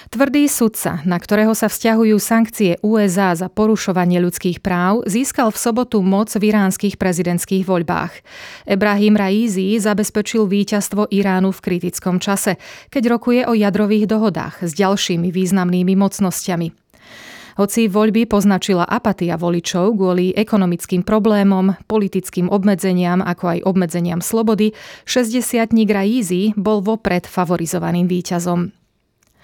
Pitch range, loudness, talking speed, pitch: 180-215 Hz, -17 LUFS, 120 wpm, 200 Hz